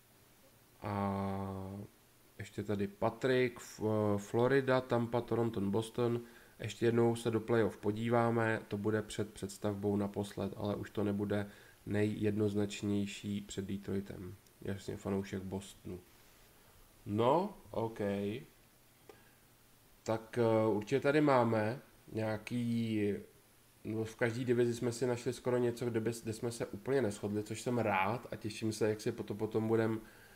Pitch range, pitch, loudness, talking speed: 100-120 Hz, 110 Hz, -36 LUFS, 120 wpm